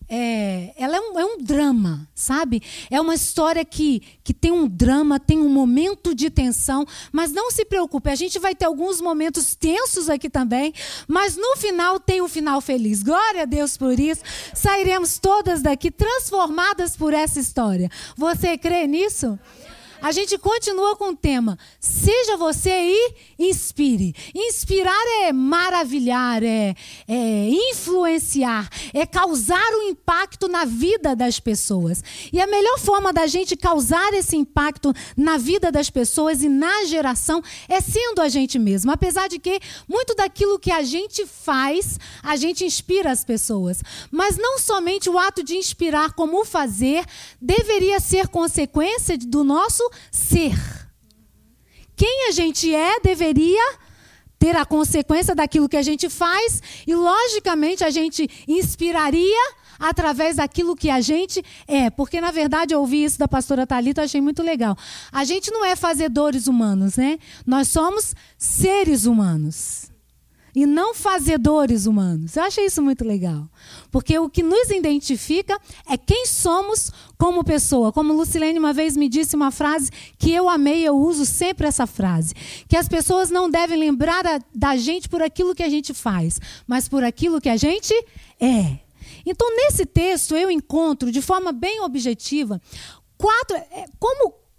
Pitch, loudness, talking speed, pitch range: 320 Hz, -20 LUFS, 155 wpm, 275-365 Hz